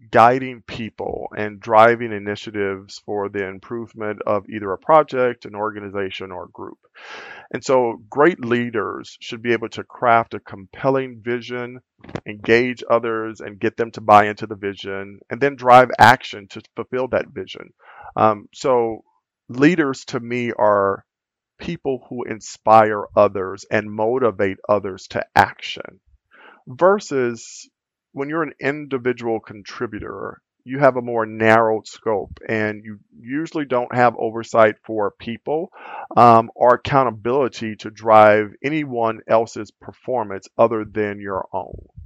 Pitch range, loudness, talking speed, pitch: 105-125 Hz, -19 LUFS, 135 wpm, 115 Hz